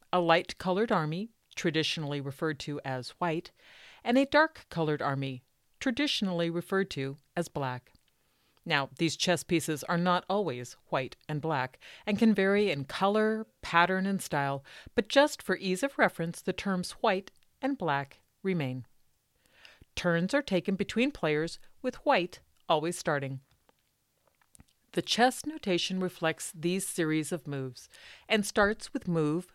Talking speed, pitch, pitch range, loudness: 140 wpm, 175 Hz, 150-205 Hz, -30 LUFS